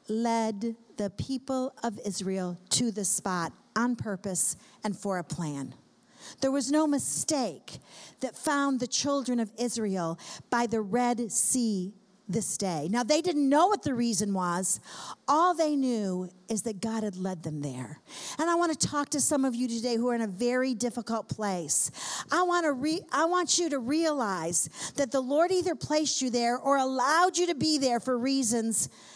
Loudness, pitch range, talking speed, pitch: -28 LUFS, 200-280 Hz, 185 wpm, 240 Hz